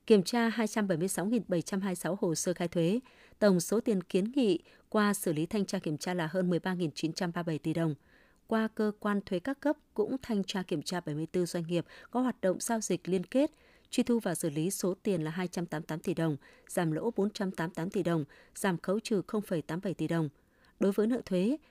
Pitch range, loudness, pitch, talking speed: 170-215 Hz, -32 LUFS, 185 Hz, 195 wpm